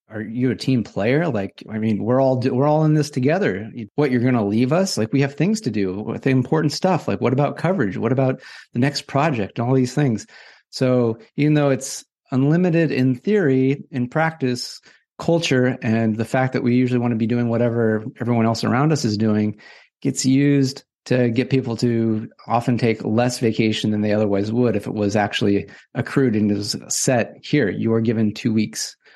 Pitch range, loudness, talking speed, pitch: 110-135 Hz, -20 LUFS, 200 wpm, 125 Hz